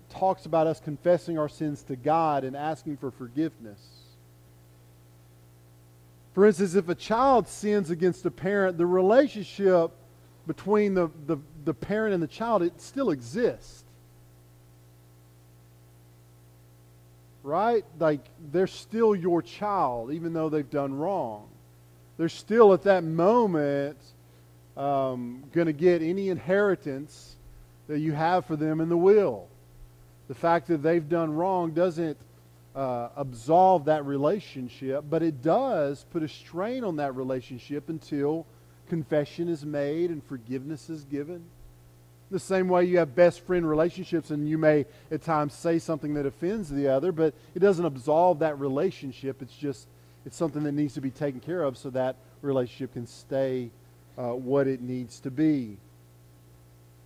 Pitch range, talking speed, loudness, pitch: 110-170 Hz, 145 wpm, -27 LUFS, 145 Hz